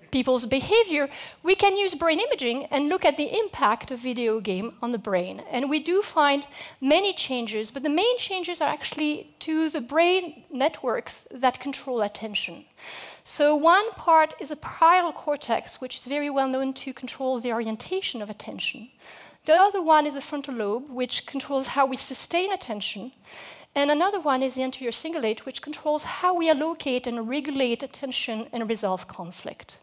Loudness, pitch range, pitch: -25 LUFS, 245-320 Hz, 275 Hz